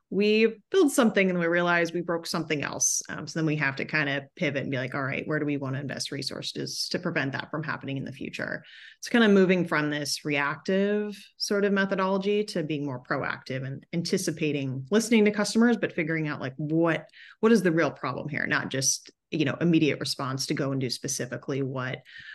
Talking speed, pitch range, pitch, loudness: 220 wpm, 140-195 Hz, 155 Hz, -27 LUFS